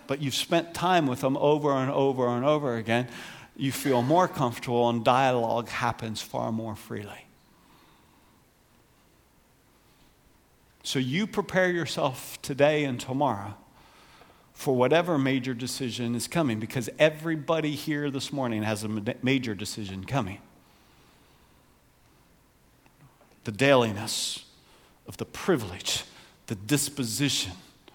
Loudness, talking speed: -27 LUFS, 110 wpm